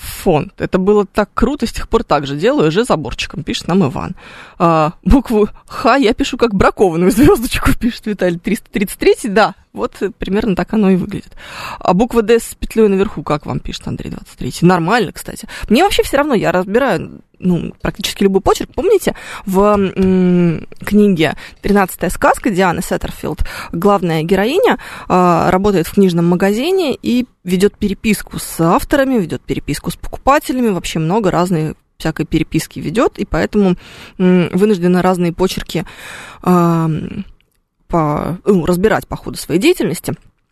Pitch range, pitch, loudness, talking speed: 175-220 Hz, 195 Hz, -15 LUFS, 150 wpm